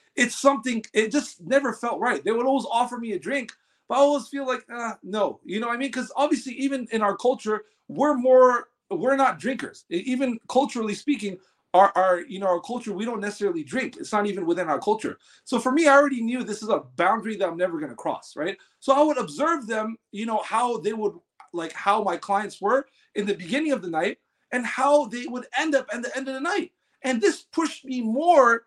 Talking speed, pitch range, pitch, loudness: 225 wpm, 210-275 Hz, 245 Hz, -24 LUFS